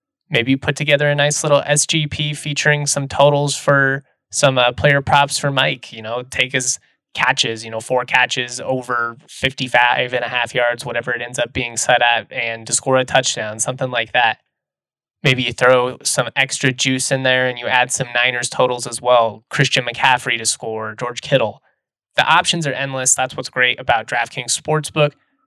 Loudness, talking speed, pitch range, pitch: -17 LUFS, 190 wpm, 120-140 Hz, 130 Hz